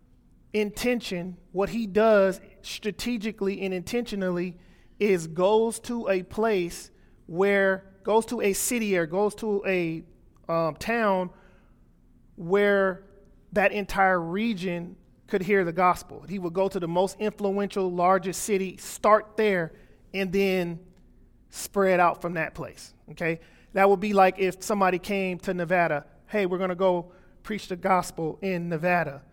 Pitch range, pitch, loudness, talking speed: 180-205 Hz, 190 Hz, -26 LUFS, 140 wpm